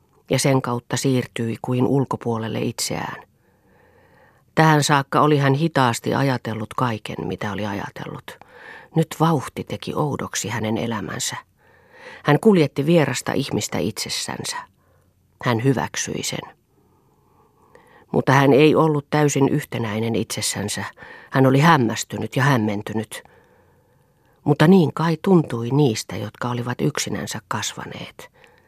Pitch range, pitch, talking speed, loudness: 110-145 Hz, 130 Hz, 110 wpm, -21 LUFS